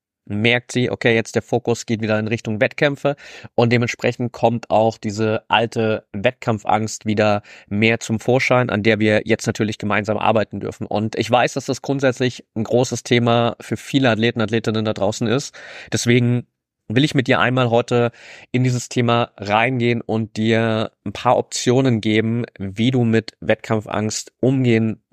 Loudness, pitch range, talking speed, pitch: -19 LUFS, 110-120 Hz, 160 wpm, 115 Hz